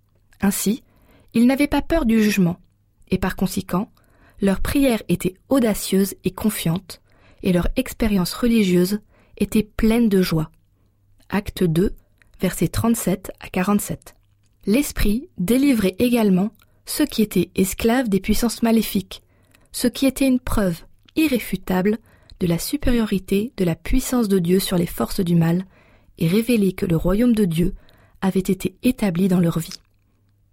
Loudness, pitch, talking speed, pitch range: -21 LUFS, 195 Hz, 140 wpm, 180-230 Hz